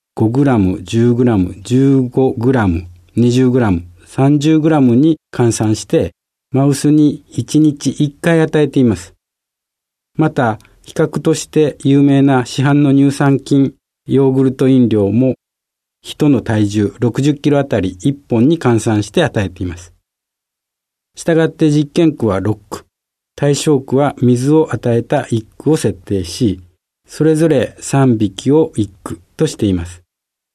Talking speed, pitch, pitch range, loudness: 205 characters per minute, 130 Hz, 110-145 Hz, -14 LUFS